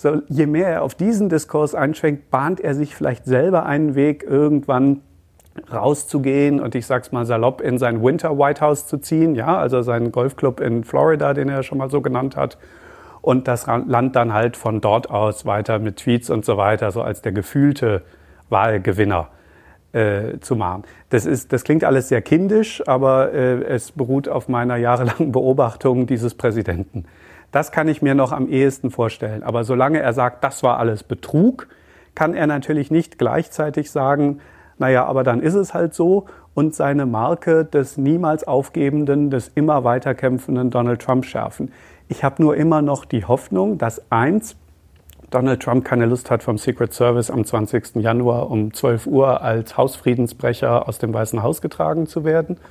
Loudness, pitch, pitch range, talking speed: -19 LUFS, 130 Hz, 120-150 Hz, 175 wpm